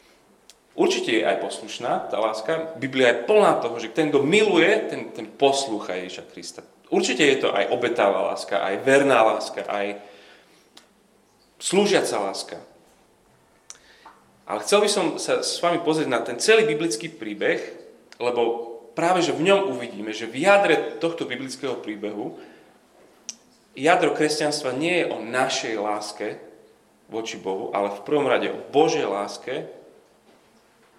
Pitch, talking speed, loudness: 140 Hz, 140 wpm, -22 LUFS